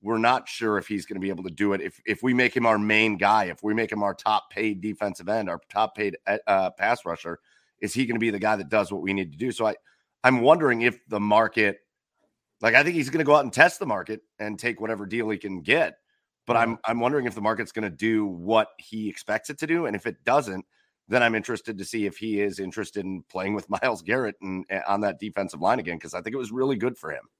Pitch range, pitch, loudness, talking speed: 100-115 Hz, 110 Hz, -25 LUFS, 275 wpm